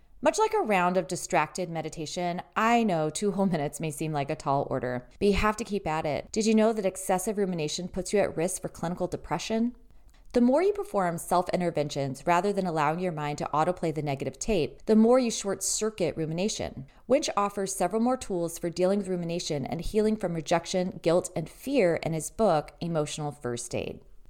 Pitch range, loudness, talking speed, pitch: 155-205 Hz, -28 LUFS, 200 wpm, 180 Hz